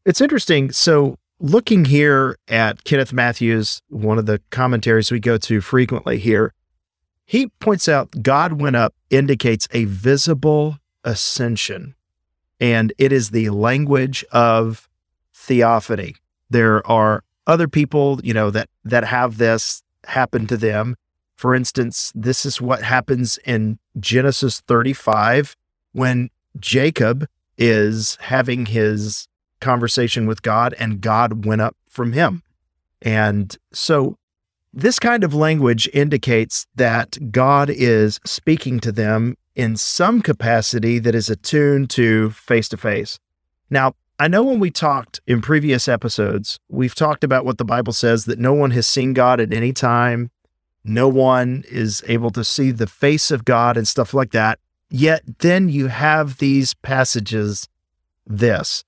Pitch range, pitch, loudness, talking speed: 110-135 Hz, 120 Hz, -17 LUFS, 140 wpm